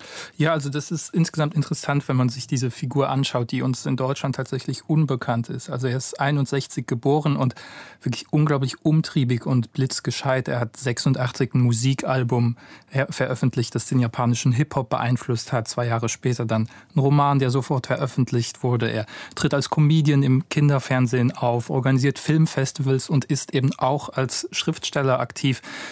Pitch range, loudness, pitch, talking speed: 125-145 Hz, -23 LUFS, 135 Hz, 155 wpm